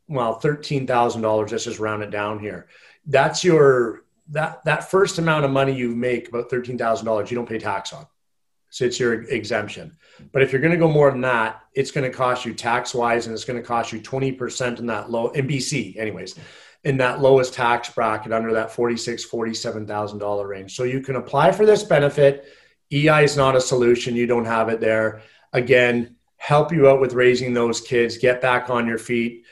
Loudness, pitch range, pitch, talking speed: -20 LUFS, 115-135 Hz, 120 Hz, 205 wpm